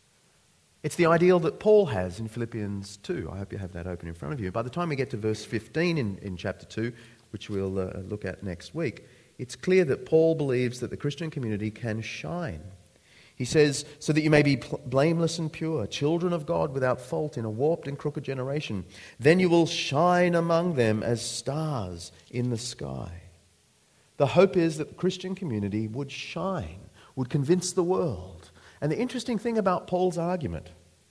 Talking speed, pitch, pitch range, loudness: 195 wpm, 130 Hz, 100-165 Hz, -27 LUFS